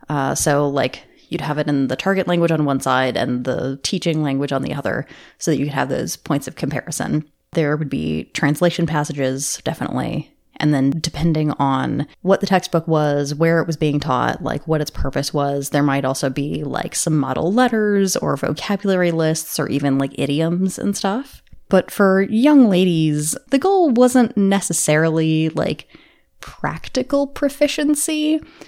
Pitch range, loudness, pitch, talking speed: 145-195 Hz, -19 LUFS, 160 Hz, 170 wpm